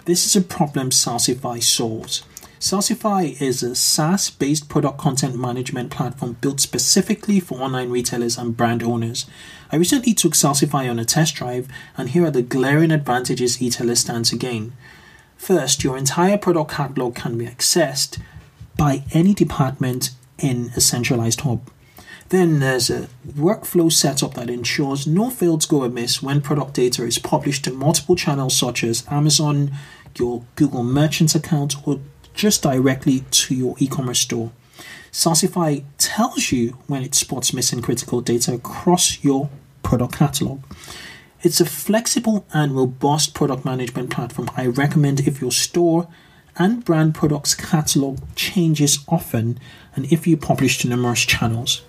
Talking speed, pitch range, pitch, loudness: 150 wpm, 125-165 Hz, 140 Hz, -19 LUFS